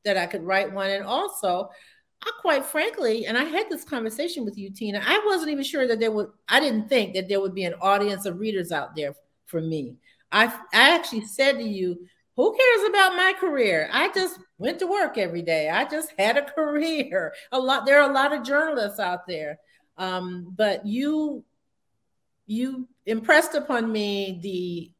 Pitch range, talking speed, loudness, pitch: 190-295 Hz, 195 wpm, -23 LUFS, 225 Hz